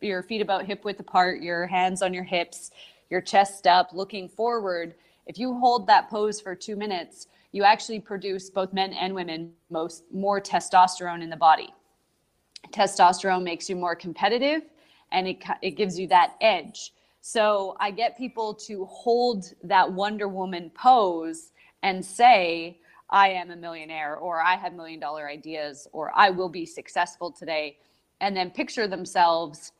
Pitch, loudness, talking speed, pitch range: 185 Hz, -24 LUFS, 165 wpm, 170-210 Hz